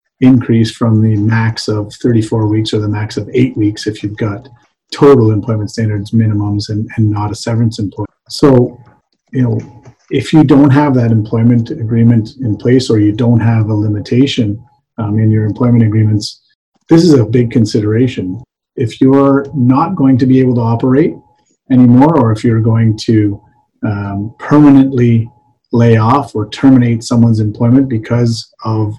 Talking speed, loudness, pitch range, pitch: 165 wpm, -11 LUFS, 110-130 Hz, 115 Hz